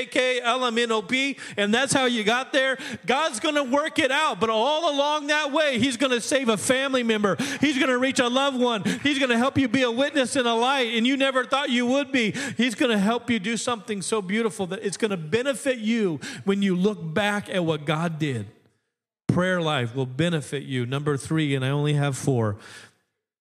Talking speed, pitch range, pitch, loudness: 230 wpm, 190-270 Hz, 235 Hz, -23 LUFS